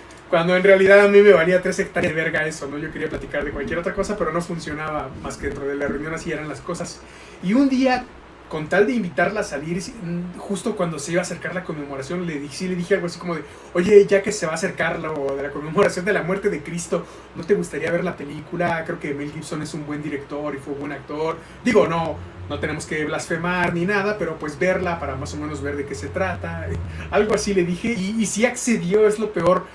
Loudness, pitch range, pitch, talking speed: -22 LUFS, 150-190 Hz, 170 Hz, 250 wpm